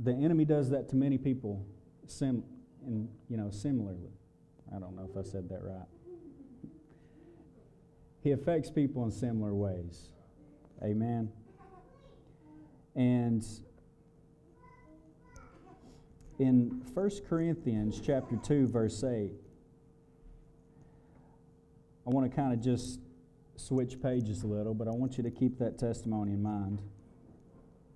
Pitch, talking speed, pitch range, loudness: 125 Hz, 120 wpm, 105-150 Hz, -34 LUFS